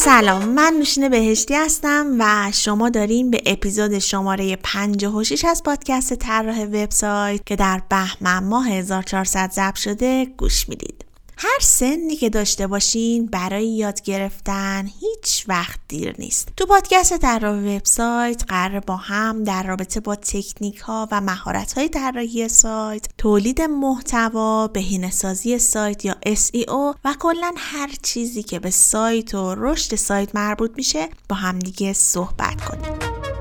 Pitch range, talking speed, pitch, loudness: 195-245 Hz, 140 wpm, 215 Hz, -19 LUFS